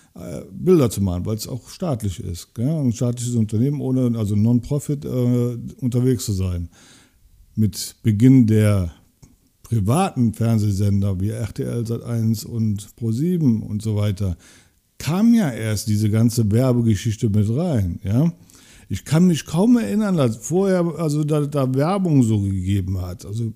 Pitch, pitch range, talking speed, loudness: 115 Hz, 105-135 Hz, 130 wpm, -20 LUFS